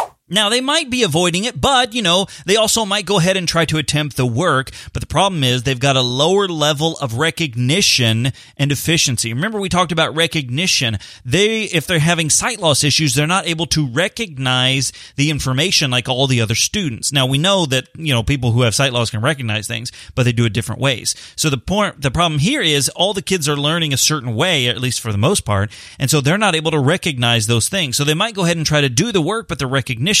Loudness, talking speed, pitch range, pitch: -16 LUFS, 240 wpm, 125-175 Hz, 150 Hz